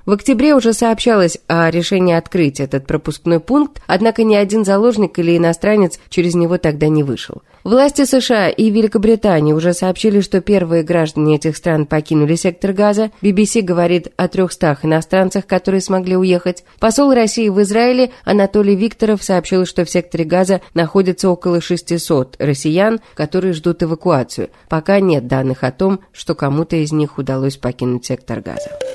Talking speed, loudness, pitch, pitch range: 155 wpm, -14 LUFS, 180 Hz, 160-210 Hz